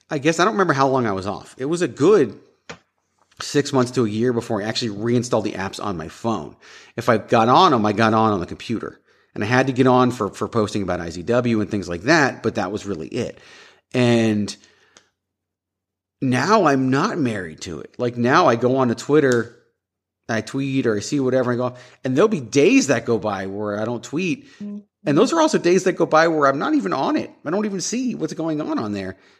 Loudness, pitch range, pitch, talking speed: -20 LUFS, 105-140 Hz, 120 Hz, 235 wpm